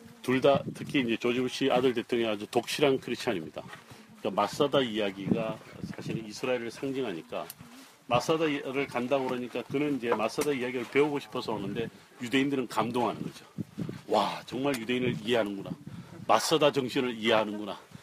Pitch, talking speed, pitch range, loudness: 125 Hz, 395 characters per minute, 120-140 Hz, -30 LUFS